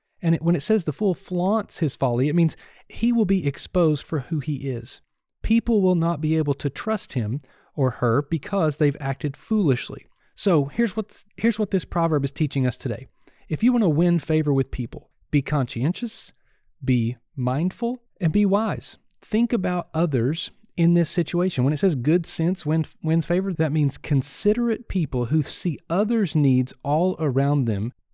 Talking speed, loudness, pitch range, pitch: 175 wpm, -23 LUFS, 140-190 Hz, 160 Hz